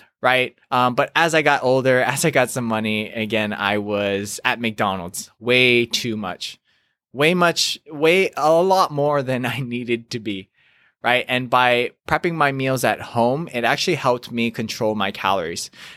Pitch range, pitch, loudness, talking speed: 110-140 Hz, 125 Hz, -19 LUFS, 175 wpm